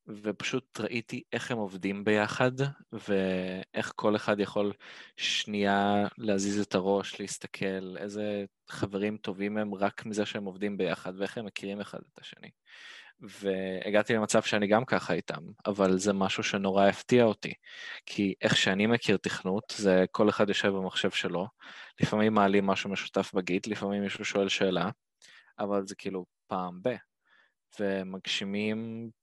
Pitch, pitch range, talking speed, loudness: 100 Hz, 95-105 Hz, 140 wpm, -30 LUFS